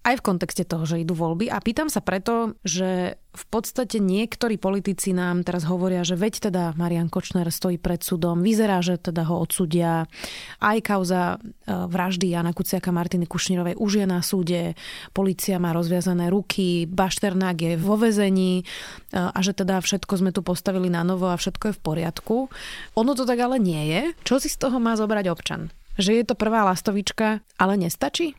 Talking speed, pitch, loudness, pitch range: 180 wpm, 185 Hz, -23 LUFS, 175-210 Hz